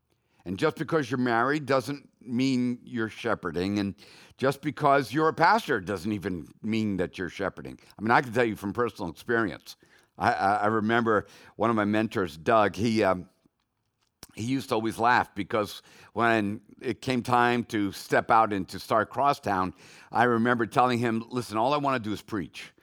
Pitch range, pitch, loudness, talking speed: 105-125 Hz, 115 Hz, -27 LUFS, 180 wpm